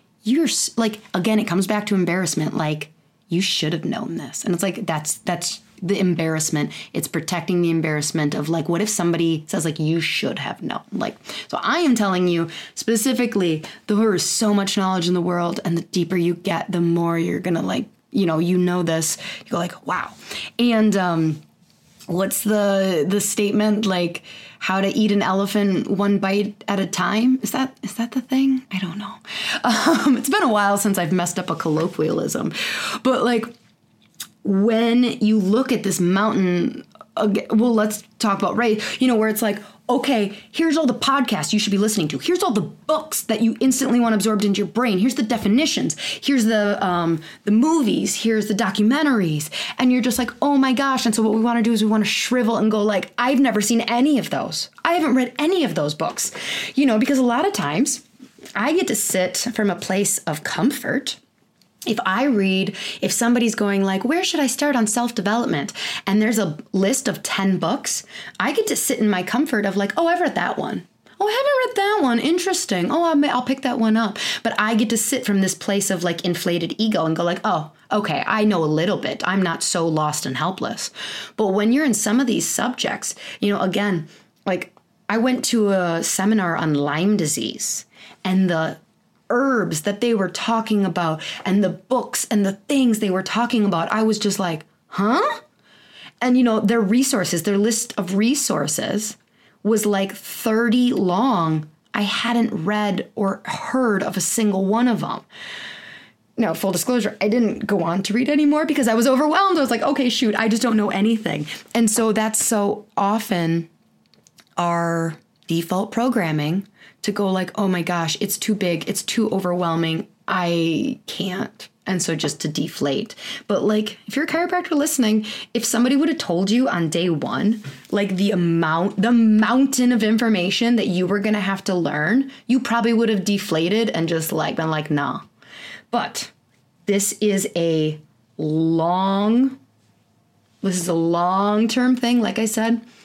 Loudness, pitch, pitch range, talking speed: -20 LUFS, 210 Hz, 180-235 Hz, 190 wpm